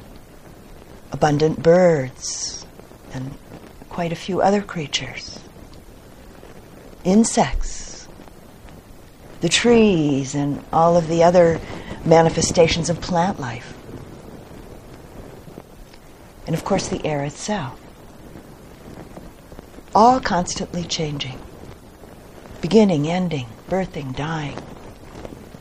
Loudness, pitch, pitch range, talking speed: -19 LUFS, 165 Hz, 140-180 Hz, 75 wpm